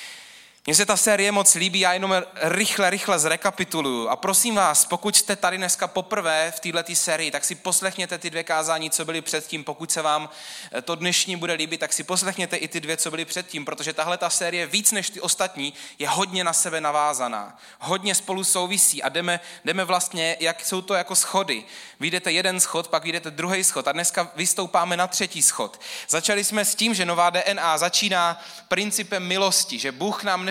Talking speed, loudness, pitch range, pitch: 195 wpm, -22 LUFS, 160-190 Hz, 175 Hz